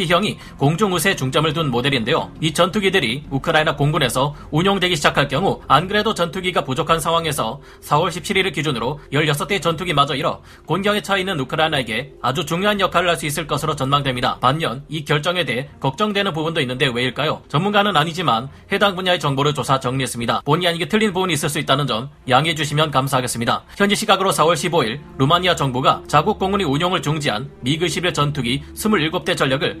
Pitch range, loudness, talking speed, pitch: 140-180 Hz, -19 LUFS, 435 characters per minute, 160 Hz